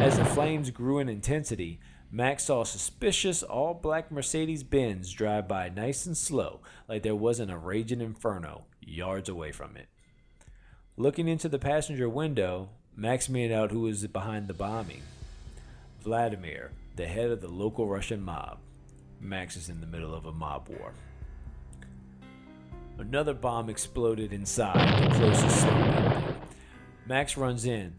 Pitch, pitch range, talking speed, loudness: 110 Hz, 85-130 Hz, 140 wpm, -30 LUFS